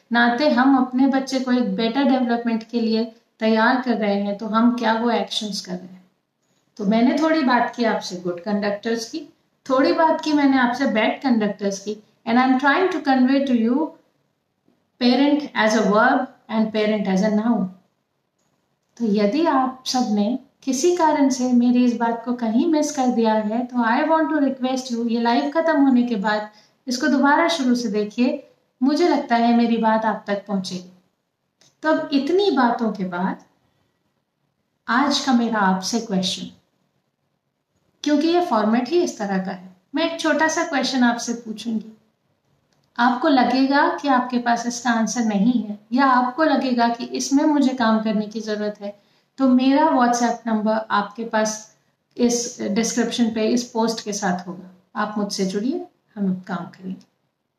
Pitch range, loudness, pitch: 215-265 Hz, -20 LUFS, 235 Hz